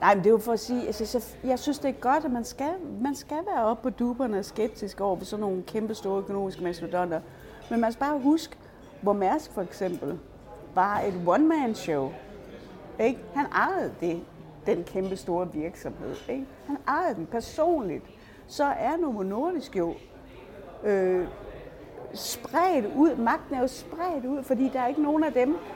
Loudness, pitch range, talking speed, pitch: -28 LUFS, 195-285 Hz, 180 wpm, 235 Hz